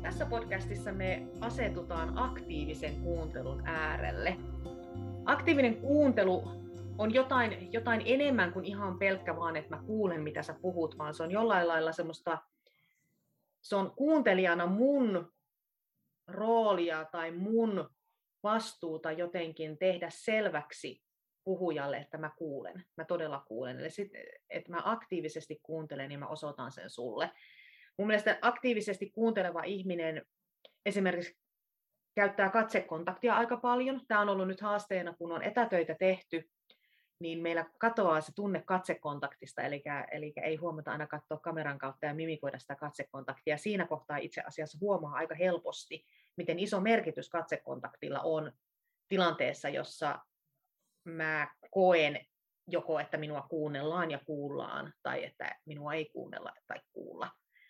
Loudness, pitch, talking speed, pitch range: -34 LUFS, 170 Hz, 130 wpm, 155-200 Hz